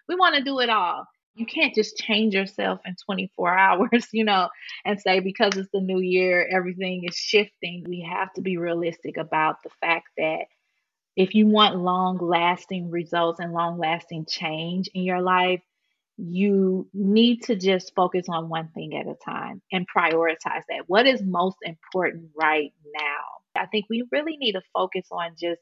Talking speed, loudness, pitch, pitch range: 180 wpm, -24 LUFS, 185 Hz, 170-210 Hz